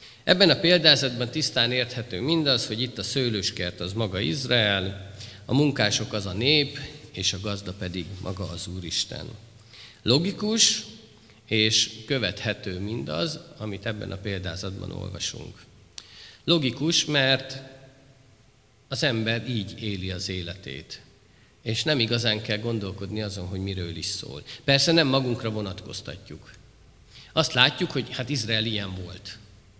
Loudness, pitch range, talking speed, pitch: -25 LUFS, 95-130 Hz, 125 wpm, 110 Hz